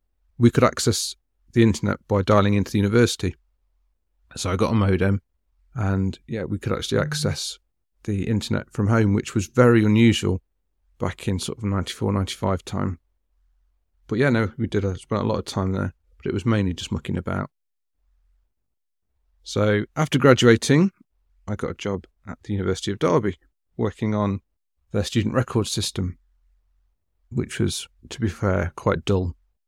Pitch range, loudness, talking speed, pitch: 90-110 Hz, -23 LUFS, 160 wpm, 100 Hz